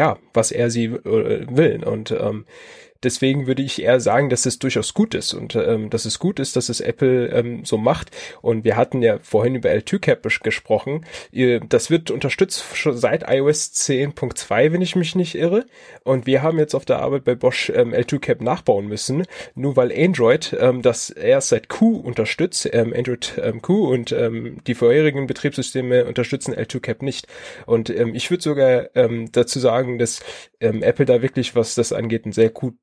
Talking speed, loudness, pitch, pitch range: 190 wpm, -19 LUFS, 130 Hz, 120-160 Hz